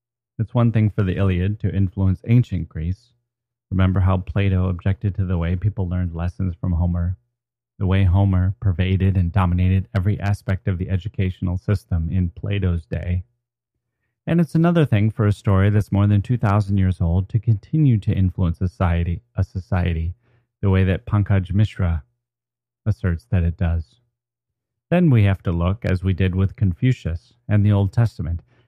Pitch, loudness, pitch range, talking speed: 95 Hz, -21 LUFS, 90-115 Hz, 165 wpm